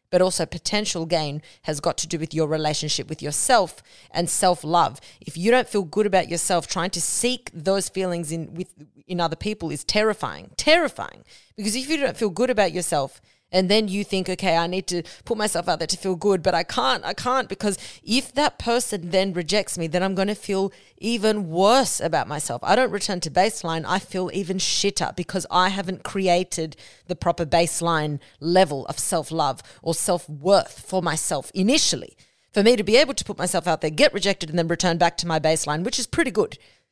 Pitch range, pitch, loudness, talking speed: 165-205 Hz, 180 Hz, -22 LUFS, 210 wpm